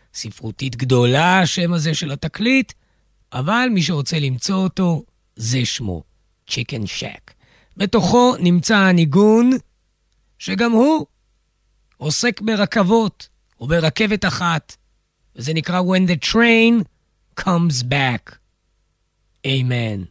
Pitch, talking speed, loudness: 155 Hz, 100 wpm, -17 LUFS